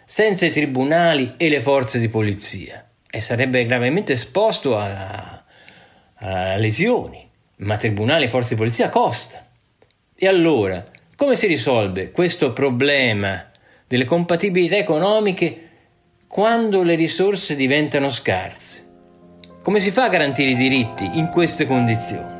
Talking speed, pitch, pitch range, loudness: 125 wpm, 135 Hz, 110-170 Hz, -18 LUFS